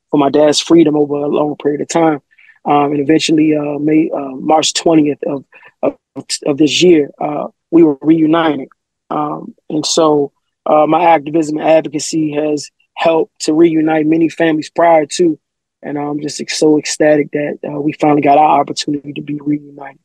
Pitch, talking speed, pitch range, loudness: 150 Hz, 175 wpm, 145-160 Hz, -13 LUFS